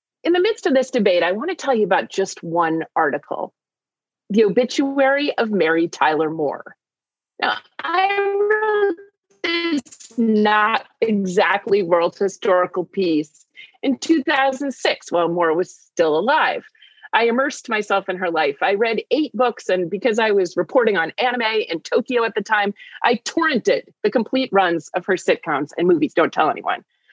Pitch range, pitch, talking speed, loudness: 185-290 Hz, 220 Hz, 160 wpm, -19 LUFS